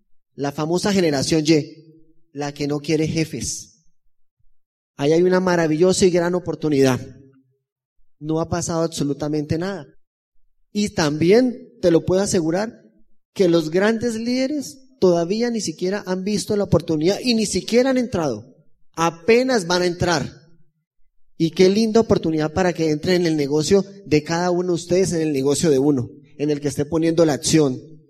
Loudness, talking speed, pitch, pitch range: -20 LUFS, 160 wpm, 165 Hz, 150-190 Hz